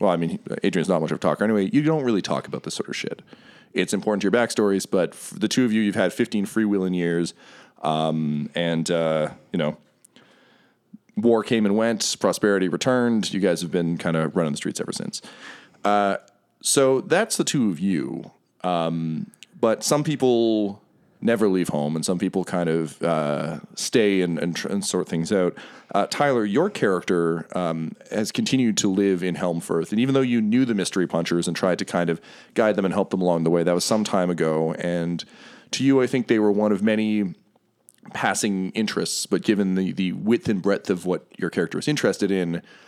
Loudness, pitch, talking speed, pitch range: -23 LUFS, 95 Hz, 205 wpm, 85-110 Hz